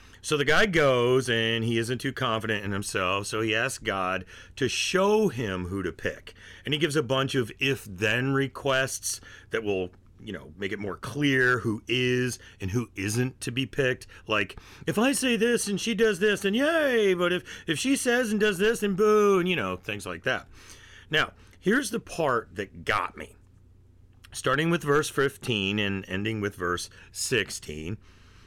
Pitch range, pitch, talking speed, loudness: 100-155 Hz, 120 Hz, 190 wpm, -26 LUFS